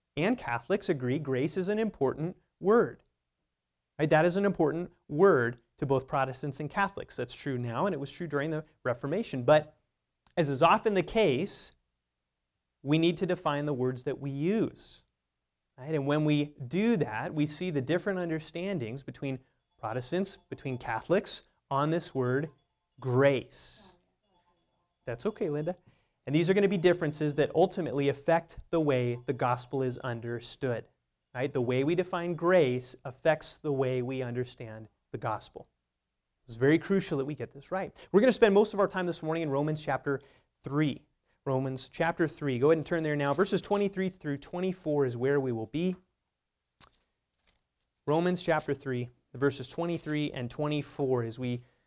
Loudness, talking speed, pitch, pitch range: -30 LUFS, 165 wpm, 145 Hz, 125-170 Hz